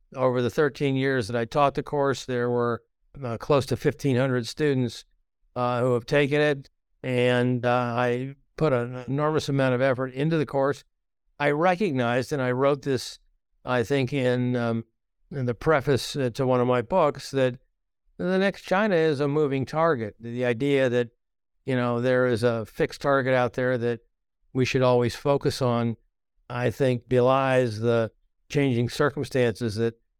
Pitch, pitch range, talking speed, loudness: 130 Hz, 120-140 Hz, 165 wpm, -25 LUFS